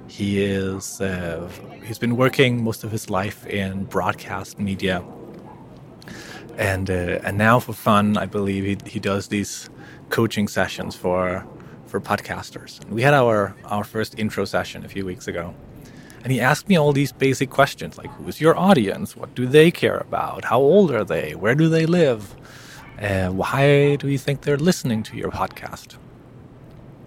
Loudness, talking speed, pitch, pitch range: -21 LUFS, 170 wpm, 110 Hz, 95-135 Hz